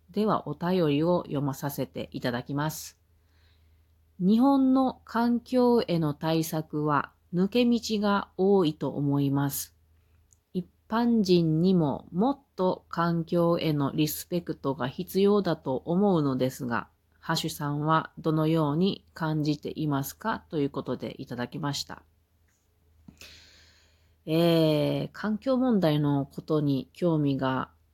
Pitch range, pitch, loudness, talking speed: 130-175 Hz, 150 Hz, -27 LUFS, 235 characters per minute